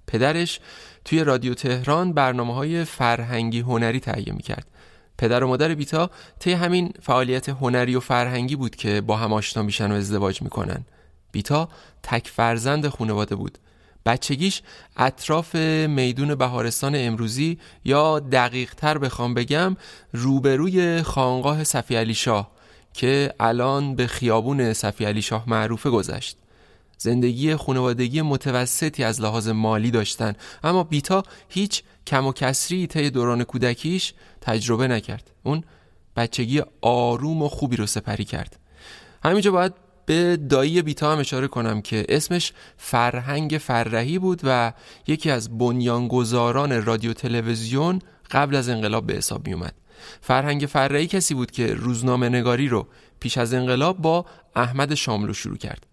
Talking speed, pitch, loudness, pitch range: 135 wpm, 125 Hz, -23 LUFS, 115-150 Hz